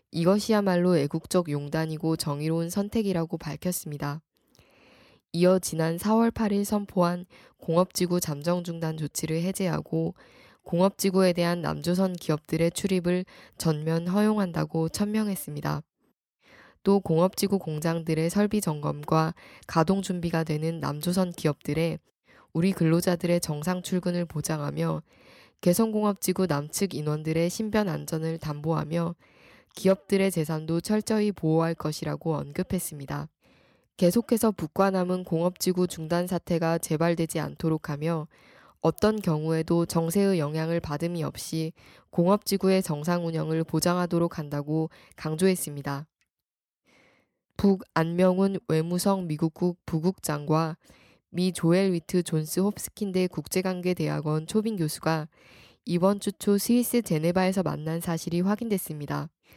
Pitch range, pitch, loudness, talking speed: 160-185 Hz, 170 Hz, -27 LUFS, 300 characters per minute